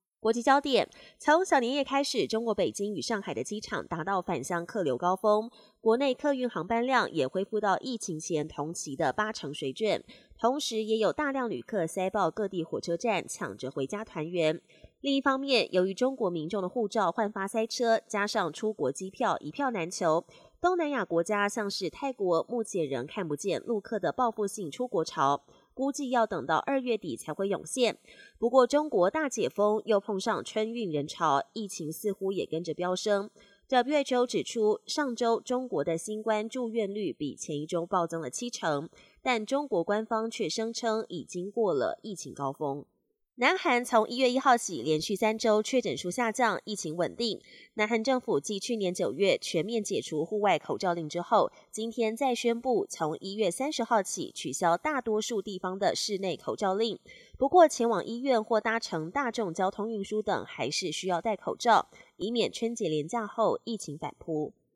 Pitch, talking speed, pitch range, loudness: 215 Hz, 275 characters per minute, 175-235 Hz, -30 LUFS